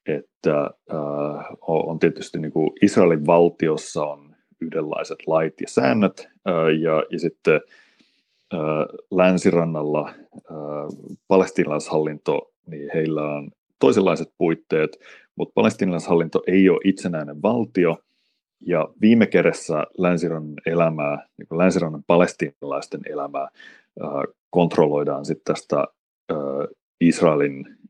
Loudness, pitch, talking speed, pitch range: -21 LUFS, 80 Hz, 100 wpm, 75-85 Hz